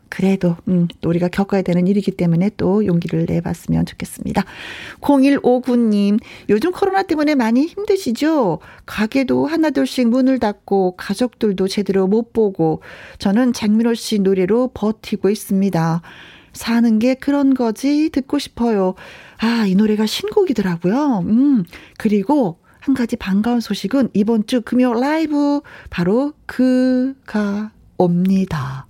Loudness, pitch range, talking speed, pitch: -17 LUFS, 195-260 Hz, 280 characters per minute, 220 Hz